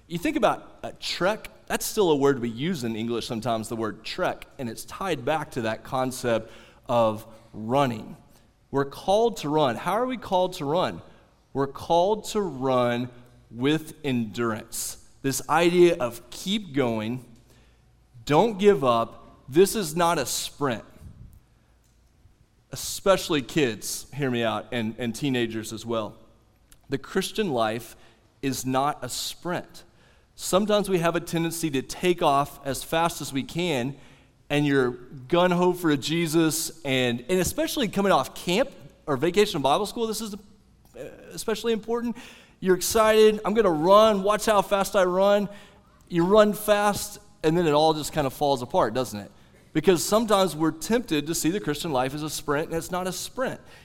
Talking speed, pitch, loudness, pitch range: 165 wpm, 150 Hz, -25 LUFS, 120-185 Hz